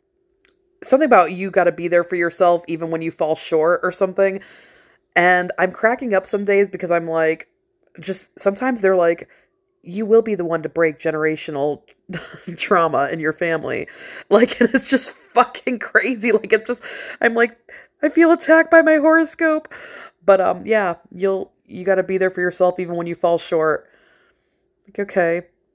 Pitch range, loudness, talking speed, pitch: 175-255 Hz, -18 LUFS, 175 wpm, 195 Hz